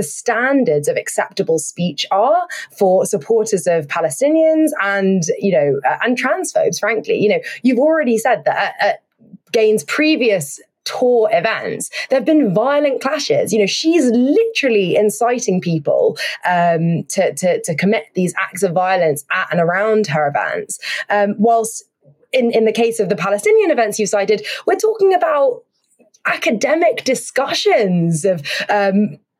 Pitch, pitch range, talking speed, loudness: 225 Hz, 190-295 Hz, 145 wpm, -16 LUFS